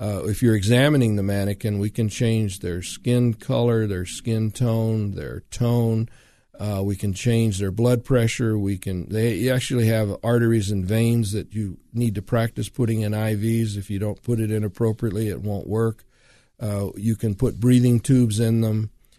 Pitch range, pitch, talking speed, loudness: 105-115 Hz, 110 Hz, 180 wpm, -22 LUFS